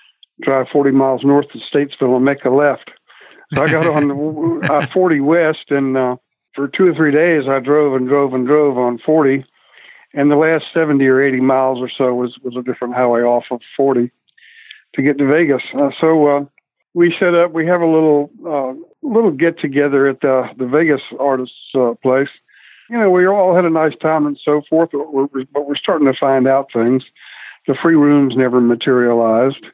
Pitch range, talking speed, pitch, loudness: 130-155 Hz, 200 wpm, 140 Hz, -15 LUFS